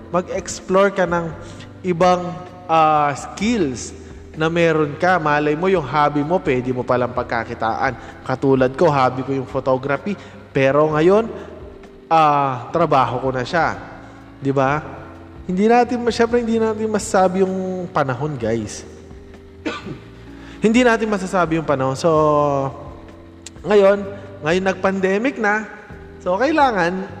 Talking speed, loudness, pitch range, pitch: 120 wpm, -18 LUFS, 130-190 Hz, 150 Hz